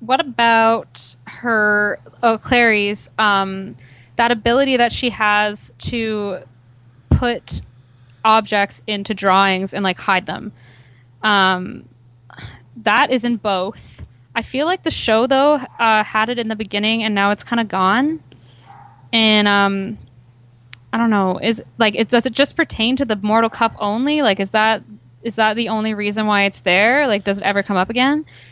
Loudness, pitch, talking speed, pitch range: -17 LUFS, 210 Hz, 160 wpm, 180-230 Hz